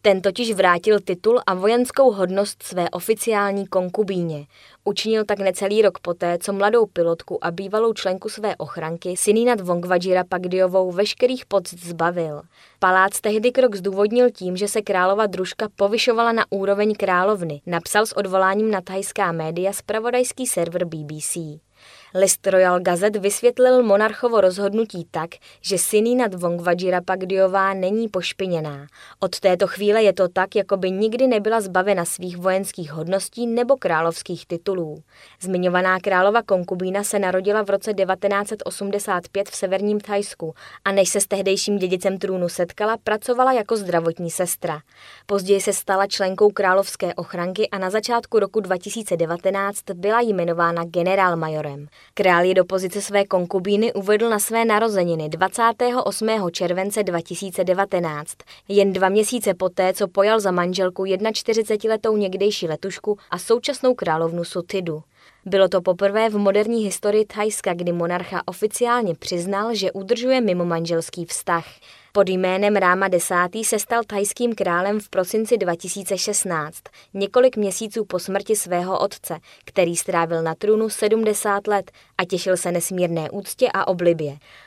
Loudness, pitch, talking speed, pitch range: -21 LUFS, 195 Hz, 135 wpm, 180-210 Hz